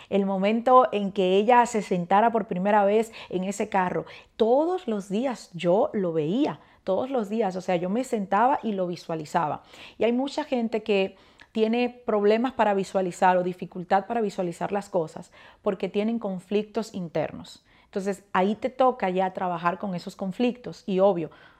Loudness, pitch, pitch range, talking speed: -25 LUFS, 200 Hz, 185-225 Hz, 165 wpm